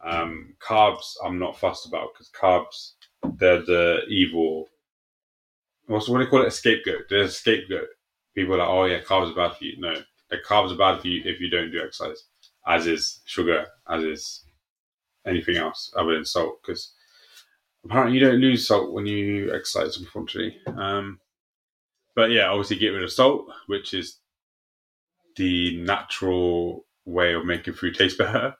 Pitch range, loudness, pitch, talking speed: 85-120 Hz, -23 LUFS, 95 Hz, 170 wpm